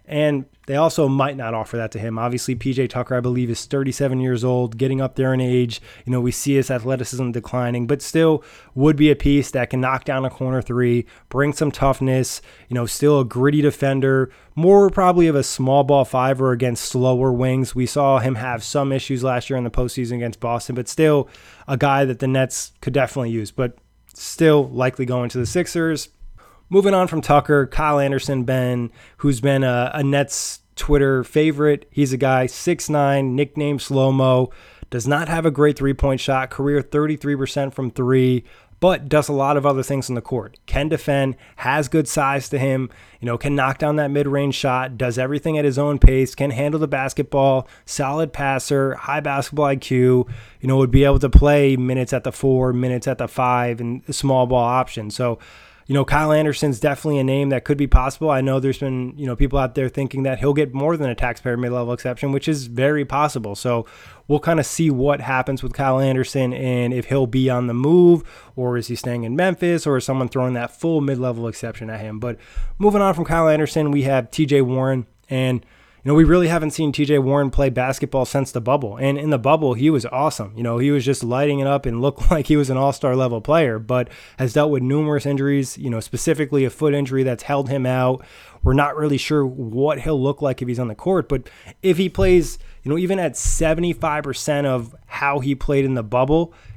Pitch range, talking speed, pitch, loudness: 125-145 Hz, 215 wpm, 135 Hz, -19 LUFS